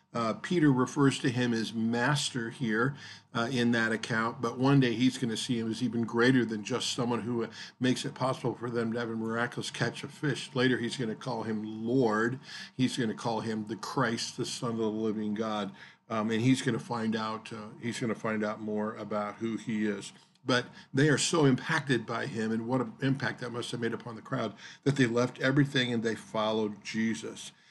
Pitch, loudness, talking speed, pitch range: 115 Hz, -31 LUFS, 225 wpm, 110-130 Hz